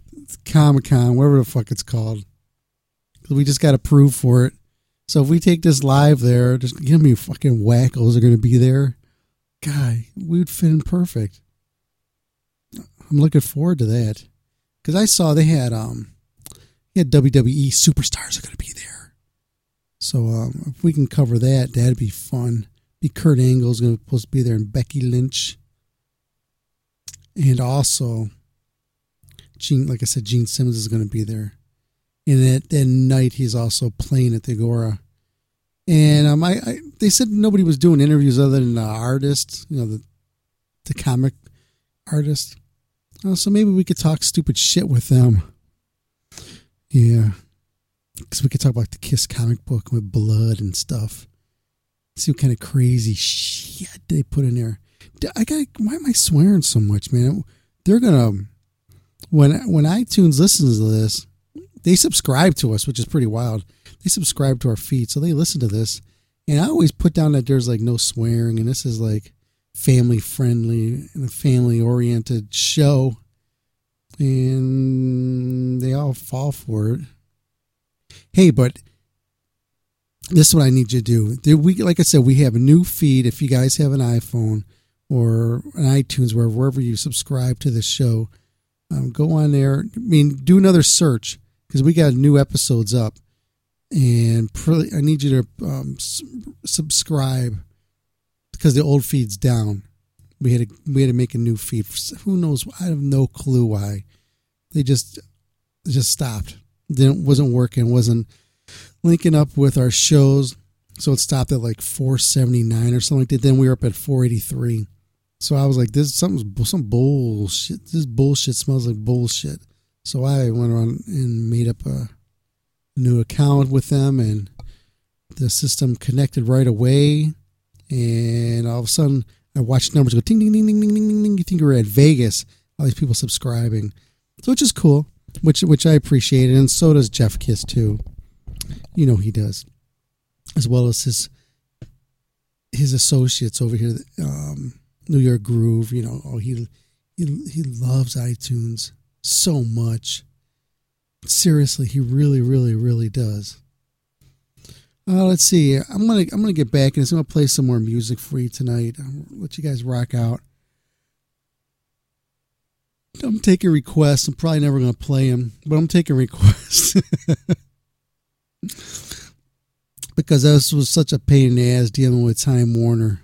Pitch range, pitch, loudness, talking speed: 115-145 Hz, 125 Hz, -17 LUFS, 165 wpm